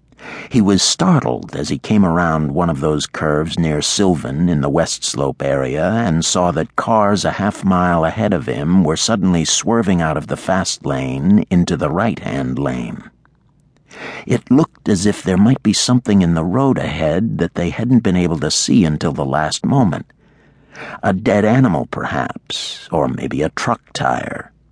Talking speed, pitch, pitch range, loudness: 175 wpm, 85 Hz, 75-100 Hz, -16 LUFS